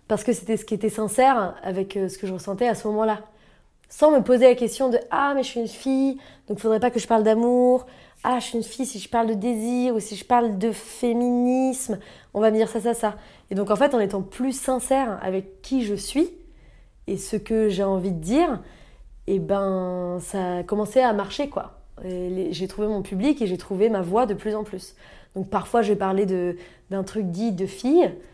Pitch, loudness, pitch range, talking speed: 220 Hz, -23 LUFS, 195-245 Hz, 235 wpm